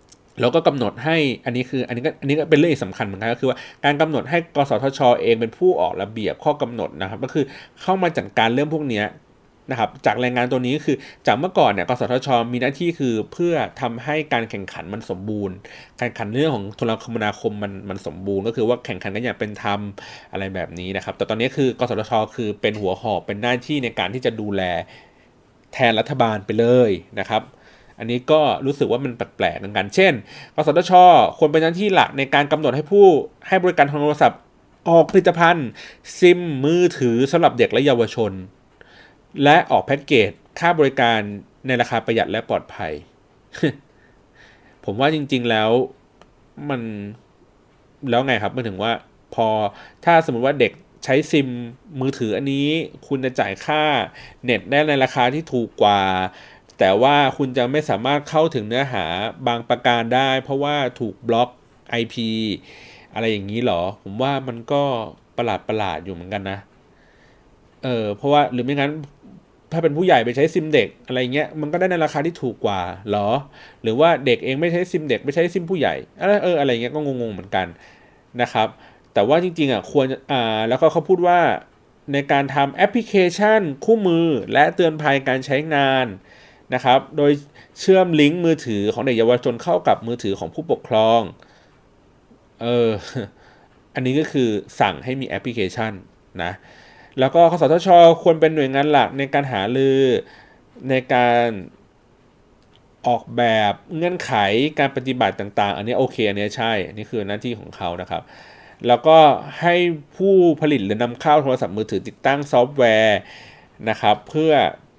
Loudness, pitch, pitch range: -19 LUFS, 130 Hz, 110-150 Hz